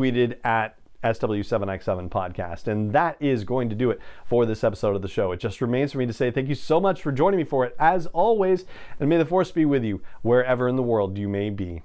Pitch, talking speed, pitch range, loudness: 125 Hz, 250 wpm, 110-145 Hz, -24 LUFS